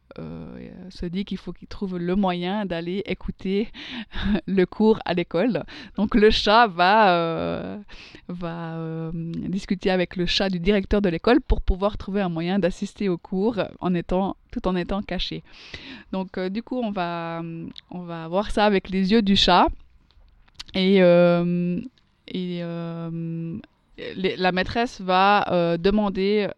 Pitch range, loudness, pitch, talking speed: 170-205 Hz, -23 LUFS, 185 Hz, 155 wpm